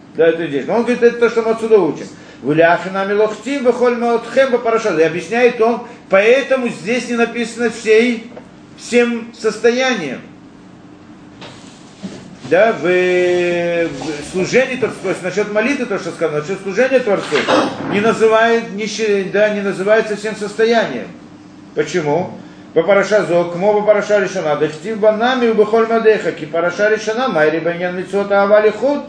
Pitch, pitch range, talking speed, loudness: 215 Hz, 185-235 Hz, 125 wpm, -15 LUFS